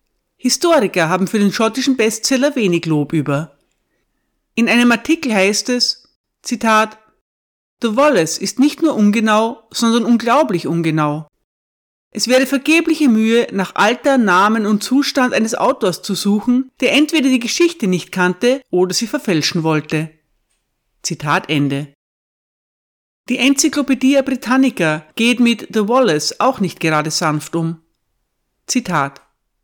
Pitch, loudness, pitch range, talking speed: 220 Hz, -15 LUFS, 170-255 Hz, 125 wpm